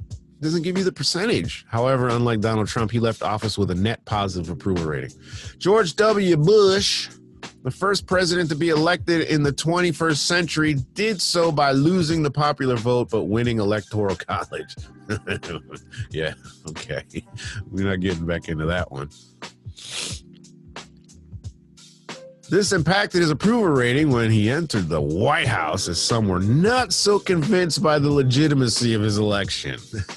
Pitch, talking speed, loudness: 130 Hz, 145 wpm, -21 LUFS